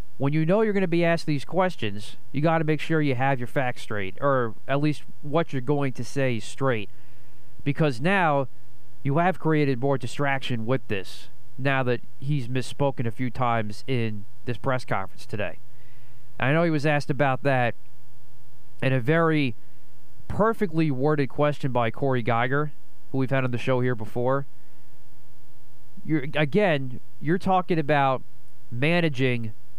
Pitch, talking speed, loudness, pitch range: 135 Hz, 160 wpm, -25 LUFS, 125-150 Hz